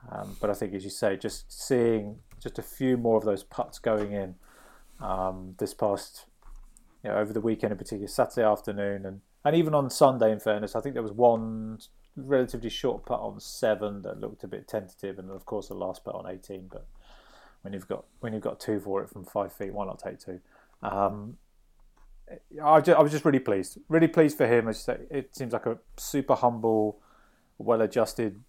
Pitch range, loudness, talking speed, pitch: 100-125 Hz, -28 LUFS, 205 wpm, 110 Hz